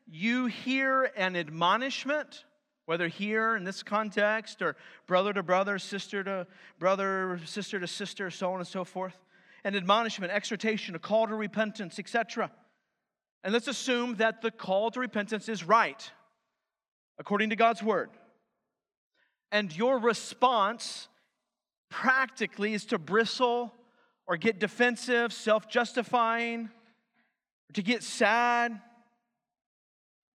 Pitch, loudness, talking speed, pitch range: 220 Hz, -29 LUFS, 120 wpm, 200-235 Hz